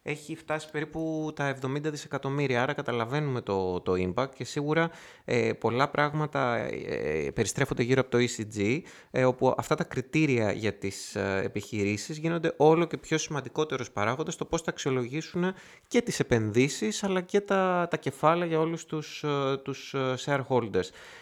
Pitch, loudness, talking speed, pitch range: 145 Hz, -29 LUFS, 150 wpm, 125-160 Hz